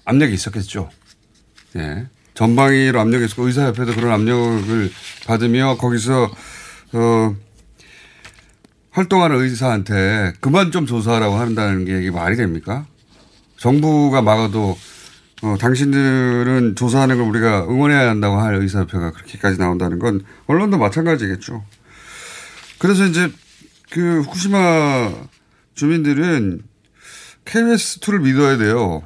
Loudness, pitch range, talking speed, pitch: -17 LUFS, 105-140 Hz, 285 characters per minute, 115 Hz